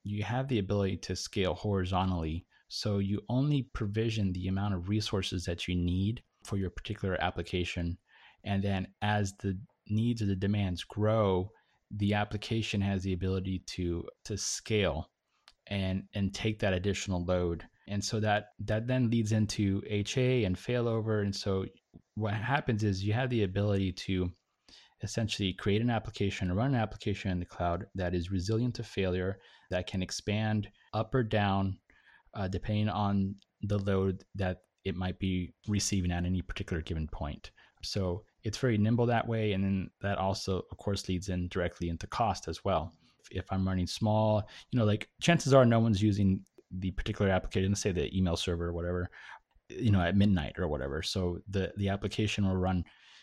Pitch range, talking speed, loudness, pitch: 90-105 Hz, 175 wpm, -32 LUFS, 100 Hz